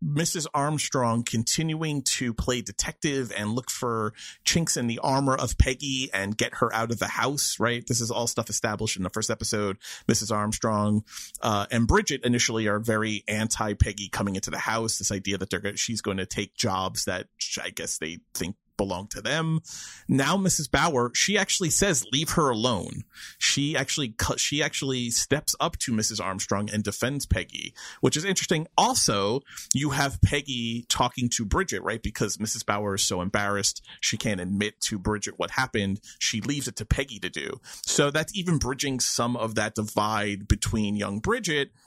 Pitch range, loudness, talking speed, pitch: 105-135 Hz, -26 LUFS, 180 wpm, 115 Hz